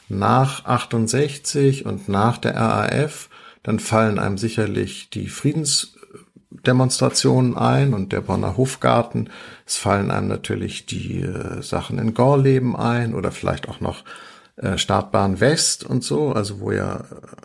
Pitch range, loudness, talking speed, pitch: 105-135 Hz, -20 LUFS, 140 wpm, 120 Hz